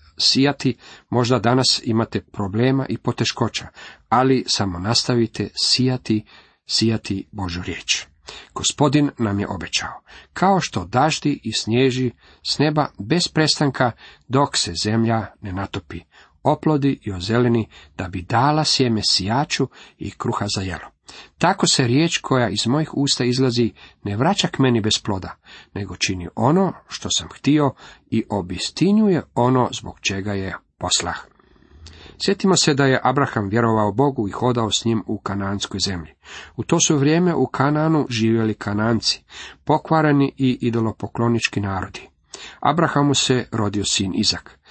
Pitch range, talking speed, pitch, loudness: 100-140 Hz, 135 wpm, 115 Hz, -20 LUFS